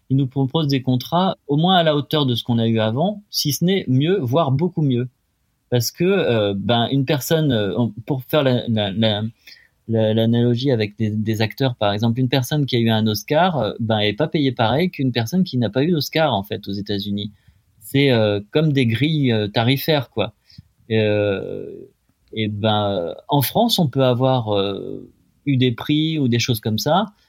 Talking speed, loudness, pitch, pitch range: 200 wpm, -19 LUFS, 125 Hz, 110-145 Hz